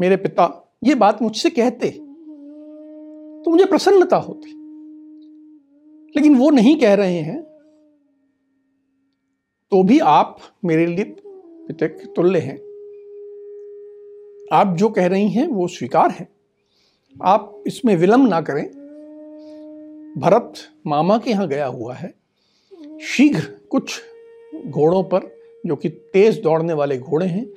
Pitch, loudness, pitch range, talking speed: 290 Hz, -17 LUFS, 205-310 Hz, 120 wpm